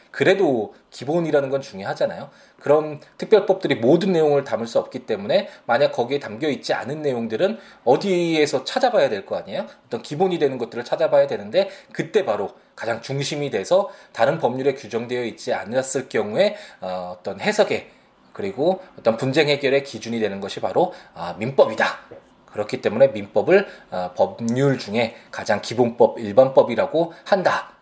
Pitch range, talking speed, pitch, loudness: 115-160 Hz, 355 characters per minute, 140 Hz, -21 LUFS